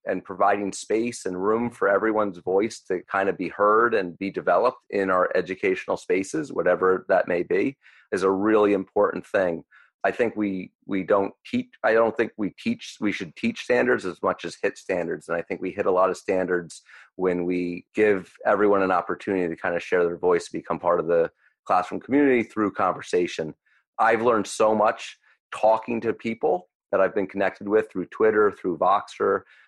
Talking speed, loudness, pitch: 195 wpm, -24 LUFS, 110 Hz